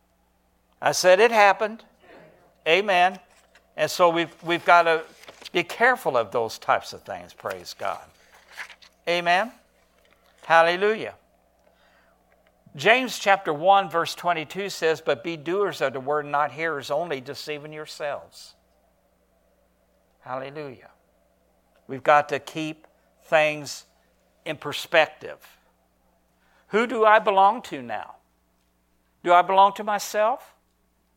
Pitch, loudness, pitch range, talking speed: 165 Hz, -22 LUFS, 135-195 Hz, 110 wpm